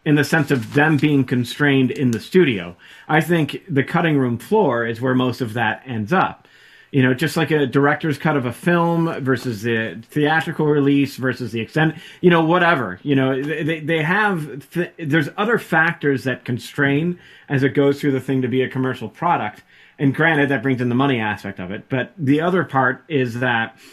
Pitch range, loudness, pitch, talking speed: 130-160 Hz, -19 LUFS, 140 Hz, 200 wpm